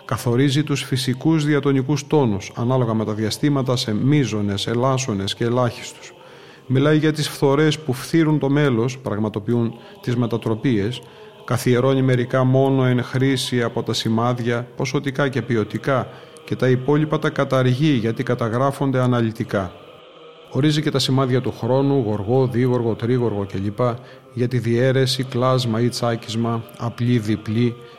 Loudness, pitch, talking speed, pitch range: -20 LUFS, 125 Hz, 130 wpm, 115-135 Hz